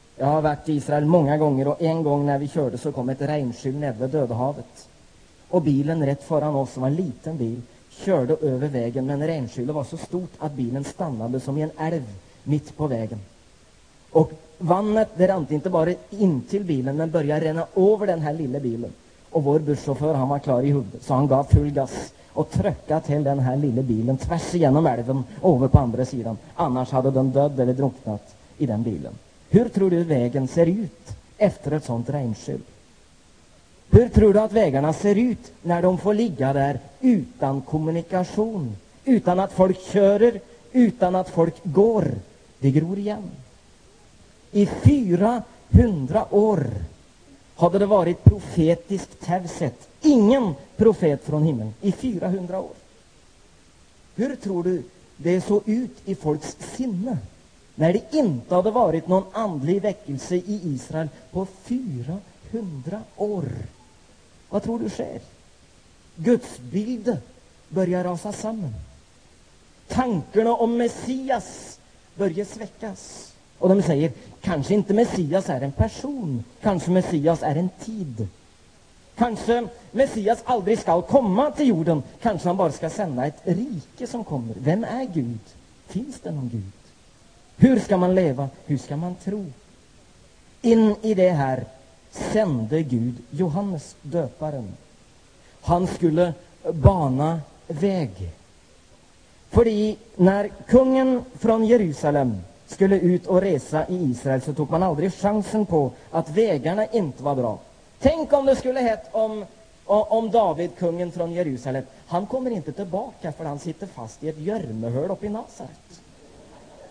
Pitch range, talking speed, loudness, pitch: 135-205 Hz, 150 wpm, -23 LUFS, 165 Hz